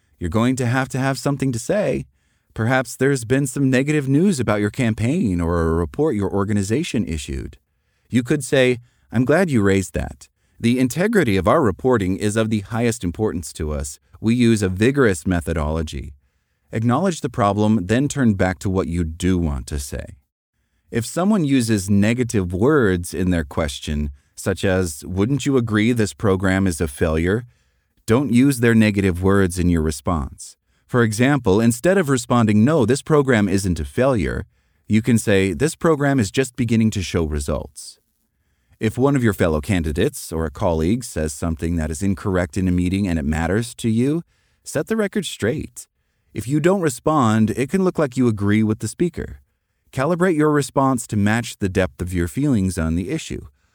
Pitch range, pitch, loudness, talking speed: 90-130 Hz, 105 Hz, -20 LUFS, 180 wpm